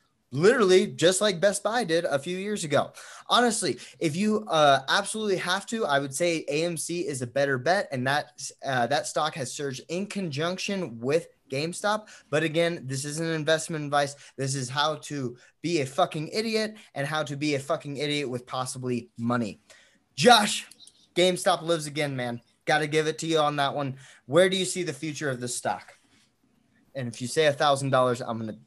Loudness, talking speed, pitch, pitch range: -26 LUFS, 190 wpm, 150 Hz, 135-180 Hz